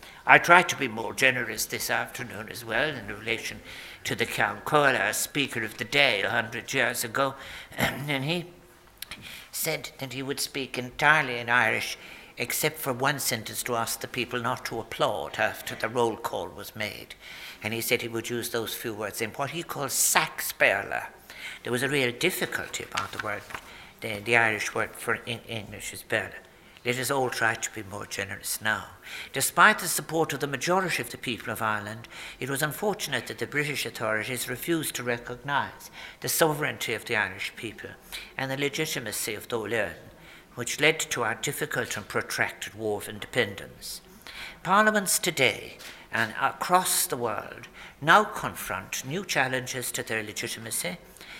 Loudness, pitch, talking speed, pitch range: -27 LUFS, 130 Hz, 170 wpm, 115-150 Hz